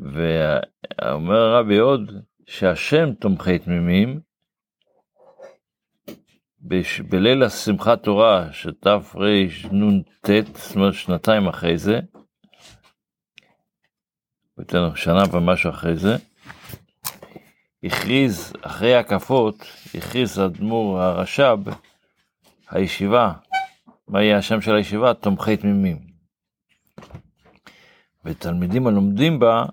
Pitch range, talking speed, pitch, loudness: 90-110 Hz, 80 wpm, 100 Hz, -19 LUFS